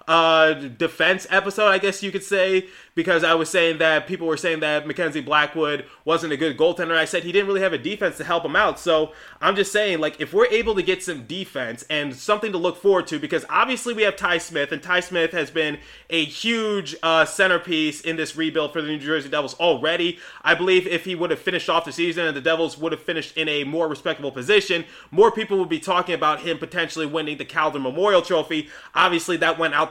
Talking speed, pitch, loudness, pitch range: 230 wpm, 165 Hz, -21 LUFS, 155-185 Hz